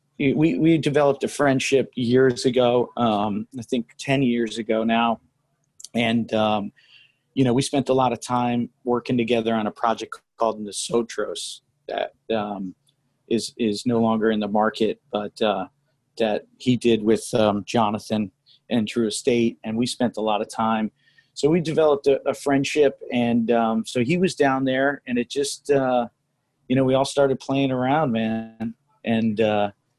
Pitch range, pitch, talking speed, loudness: 110-135 Hz, 120 Hz, 170 wpm, -22 LUFS